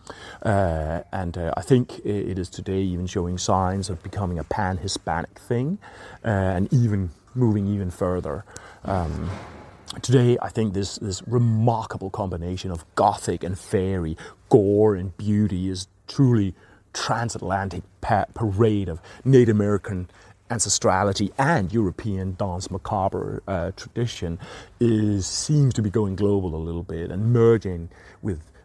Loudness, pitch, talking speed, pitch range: -24 LUFS, 100 Hz, 135 wpm, 90-110 Hz